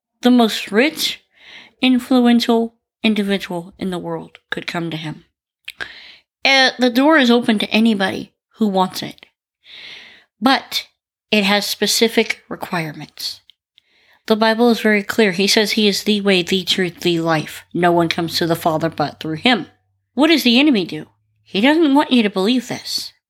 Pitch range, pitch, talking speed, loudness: 175-240 Hz, 210 Hz, 160 wpm, -16 LUFS